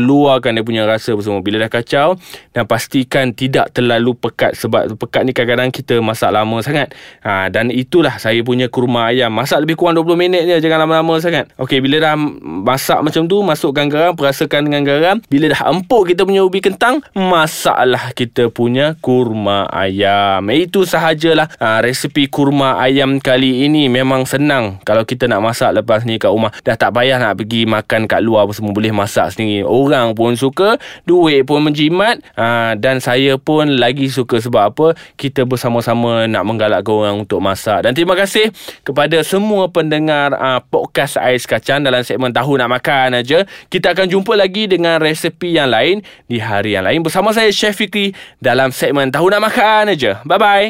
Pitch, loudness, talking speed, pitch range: 135 Hz, -13 LUFS, 180 wpm, 120-165 Hz